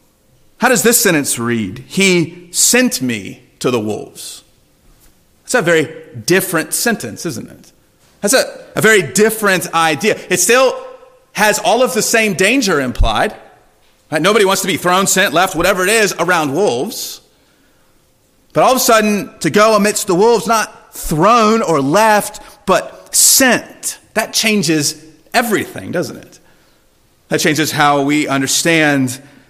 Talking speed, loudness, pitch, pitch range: 145 wpm, -13 LUFS, 195 Hz, 160-225 Hz